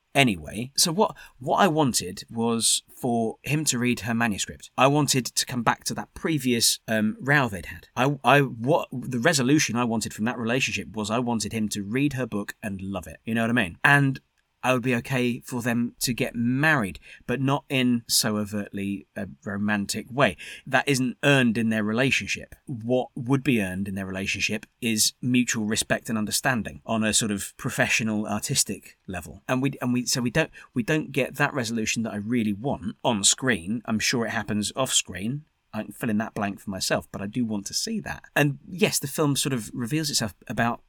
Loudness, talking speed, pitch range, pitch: -25 LUFS, 210 wpm, 110-135 Hz, 120 Hz